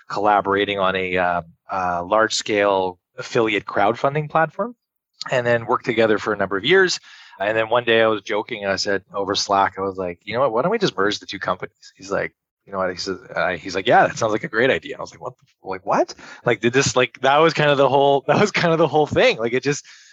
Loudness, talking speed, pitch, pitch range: -20 LUFS, 260 wpm, 115 Hz, 100-140 Hz